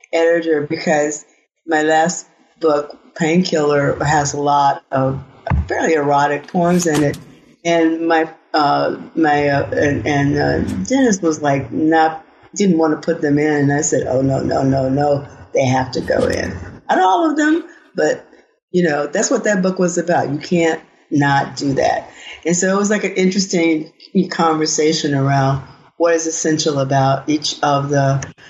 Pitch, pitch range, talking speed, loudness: 155 Hz, 145-170 Hz, 170 wpm, -16 LUFS